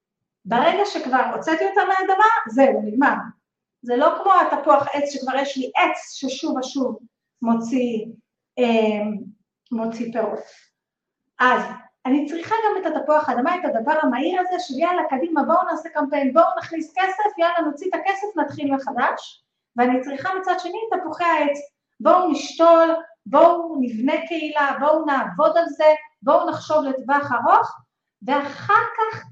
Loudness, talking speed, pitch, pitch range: -20 LUFS, 140 wpm, 295 Hz, 255-335 Hz